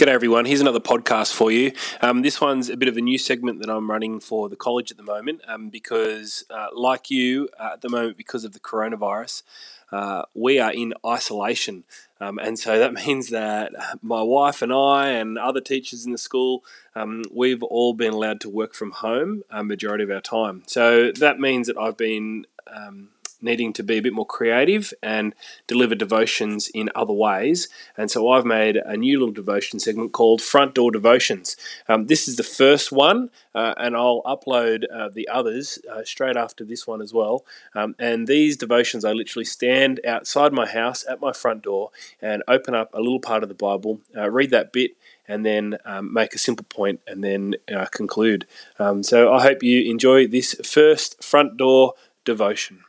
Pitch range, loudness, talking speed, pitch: 110-130 Hz, -21 LUFS, 200 wpm, 120 Hz